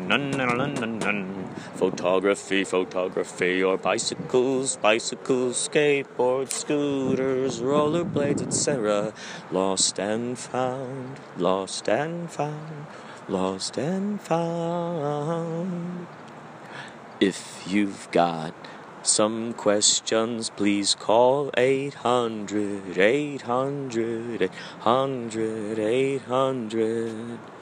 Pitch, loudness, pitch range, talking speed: 125 Hz, -25 LUFS, 105-145 Hz, 85 wpm